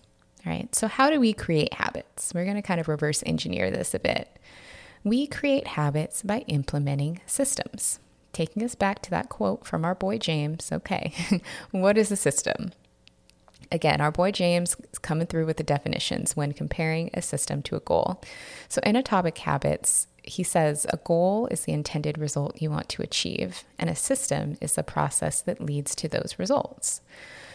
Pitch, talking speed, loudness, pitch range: 165 Hz, 180 wpm, -26 LUFS, 150-200 Hz